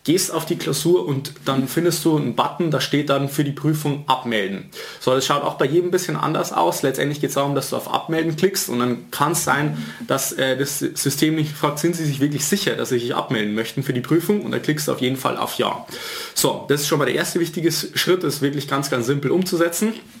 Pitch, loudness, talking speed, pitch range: 145 Hz, -21 LUFS, 250 wpm, 135-170 Hz